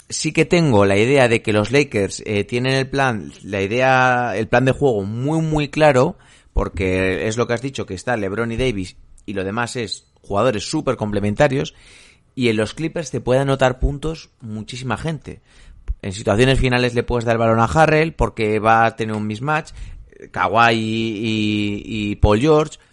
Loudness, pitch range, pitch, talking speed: -18 LUFS, 105-135 Hz, 115 Hz, 185 wpm